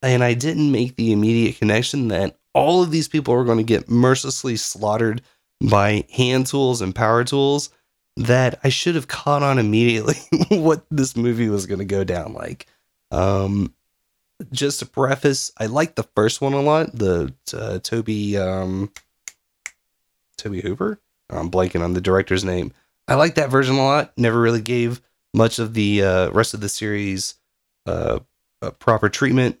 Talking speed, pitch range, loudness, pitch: 170 wpm, 100-135 Hz, -20 LUFS, 115 Hz